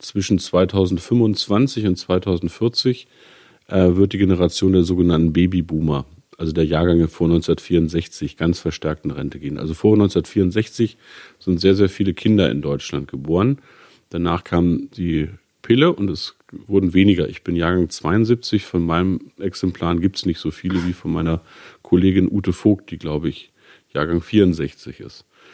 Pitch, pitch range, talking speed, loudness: 90 Hz, 85-100 Hz, 150 wpm, -19 LUFS